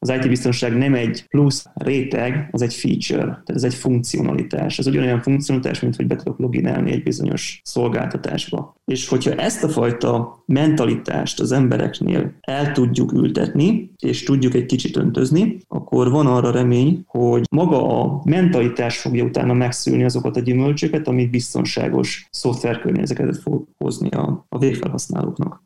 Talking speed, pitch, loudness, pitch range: 145 wpm, 125 Hz, -19 LUFS, 120-145 Hz